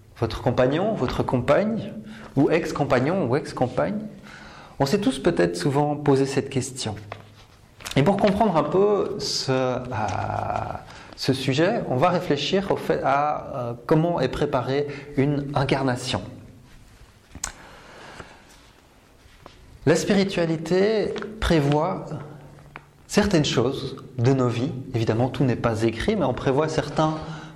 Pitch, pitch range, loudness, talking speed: 135 Hz, 120-160 Hz, -23 LUFS, 120 wpm